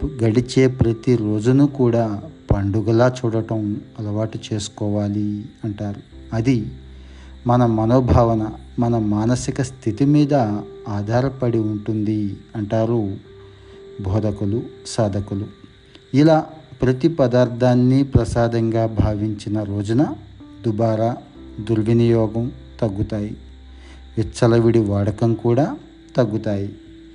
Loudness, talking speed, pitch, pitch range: -20 LUFS, 75 wpm, 110 Hz, 105-125 Hz